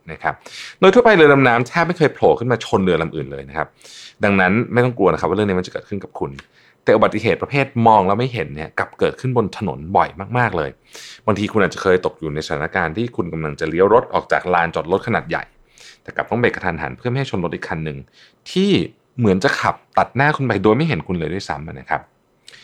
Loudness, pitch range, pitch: -18 LUFS, 80-130 Hz, 110 Hz